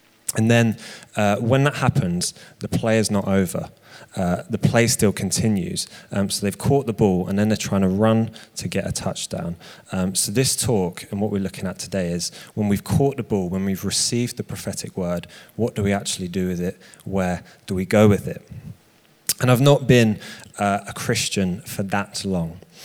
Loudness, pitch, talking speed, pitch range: -22 LUFS, 105 Hz, 200 wpm, 95-115 Hz